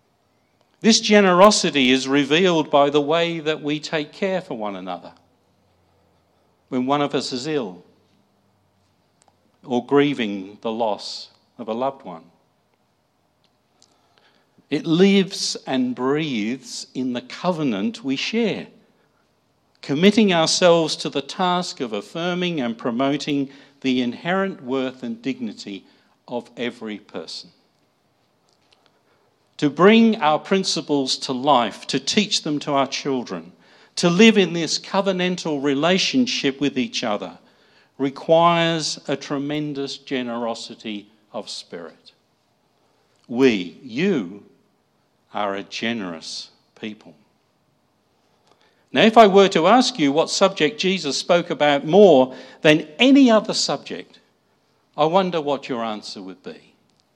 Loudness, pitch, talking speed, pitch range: -19 LUFS, 145 Hz, 115 wpm, 120-180 Hz